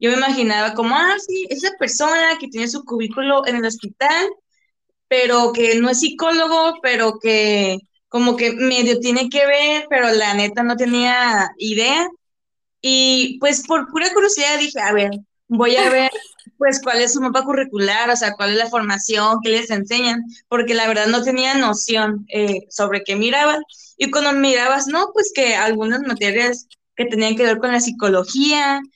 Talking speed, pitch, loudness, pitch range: 175 wpm, 245 Hz, -17 LUFS, 225-280 Hz